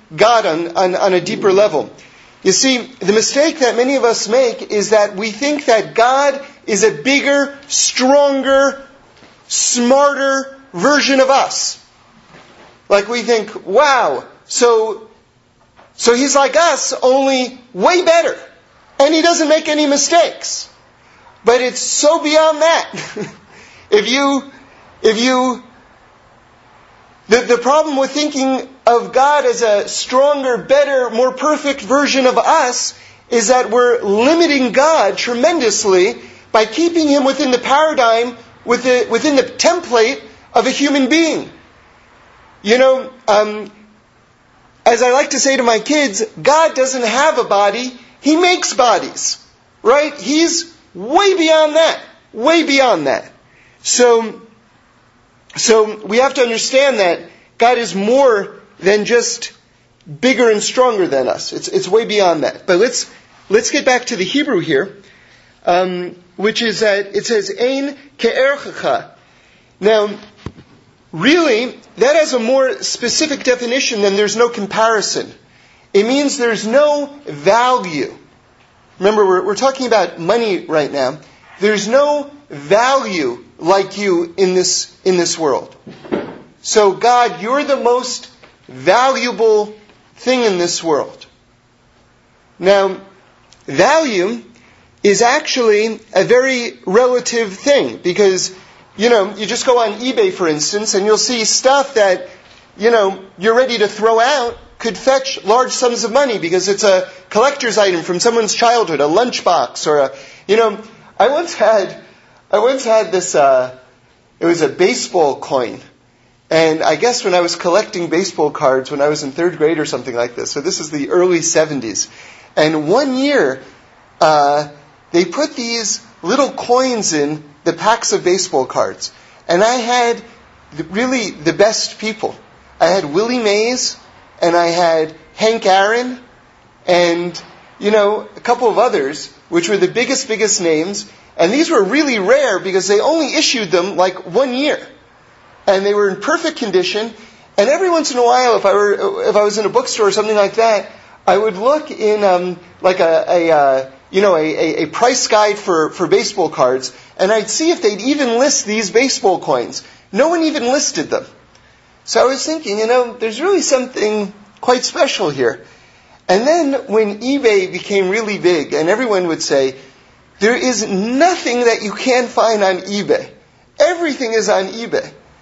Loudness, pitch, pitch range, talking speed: -14 LUFS, 230 Hz, 195-270 Hz, 150 wpm